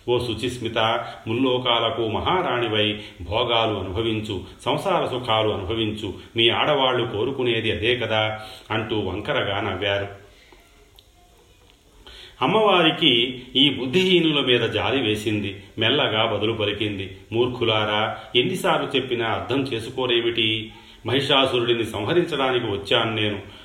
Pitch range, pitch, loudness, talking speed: 105-125 Hz, 115 Hz, -22 LUFS, 90 wpm